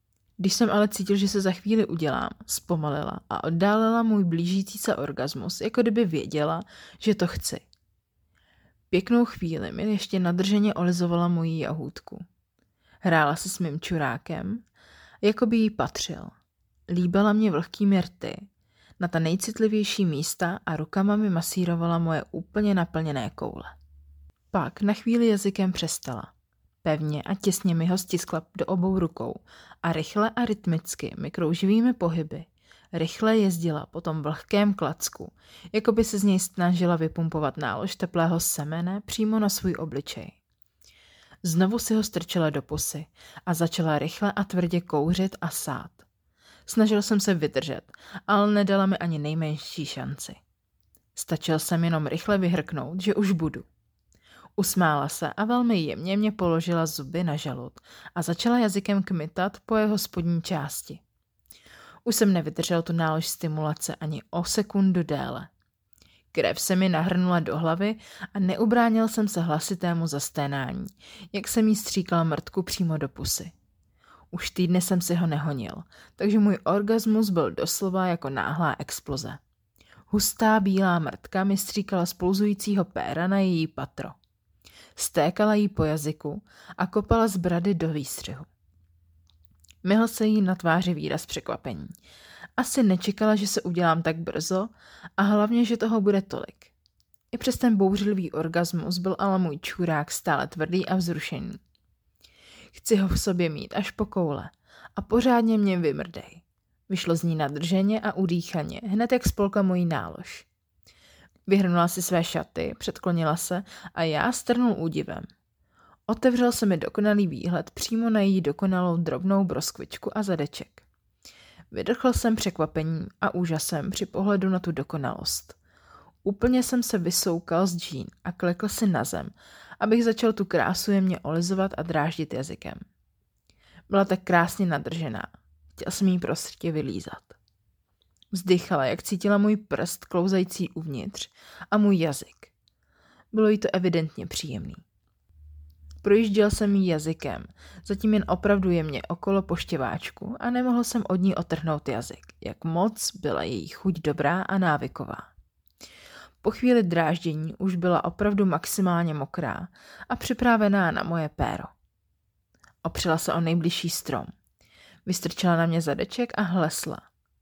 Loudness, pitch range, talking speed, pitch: -26 LUFS, 160-205 Hz, 140 wpm, 180 Hz